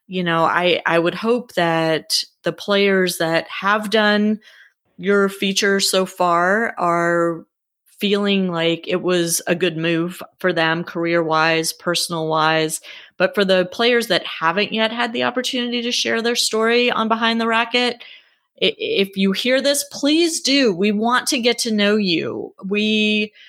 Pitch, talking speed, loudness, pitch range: 195 Hz, 160 wpm, -18 LUFS, 170-230 Hz